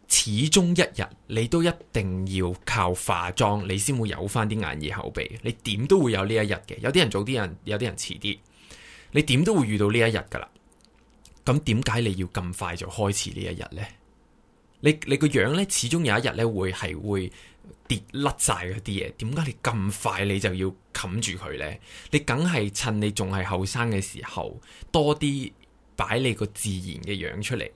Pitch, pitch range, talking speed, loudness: 110 Hz, 95-130 Hz, 265 characters per minute, -25 LUFS